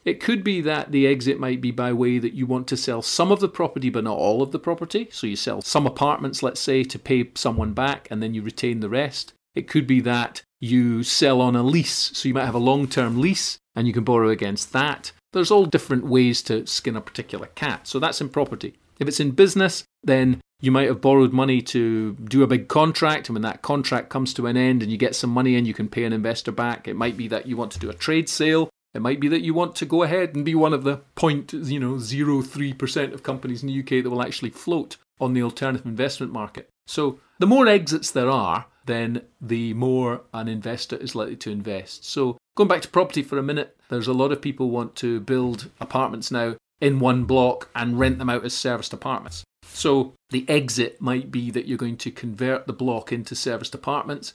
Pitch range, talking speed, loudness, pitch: 120-140 Hz, 235 wpm, -22 LUFS, 130 Hz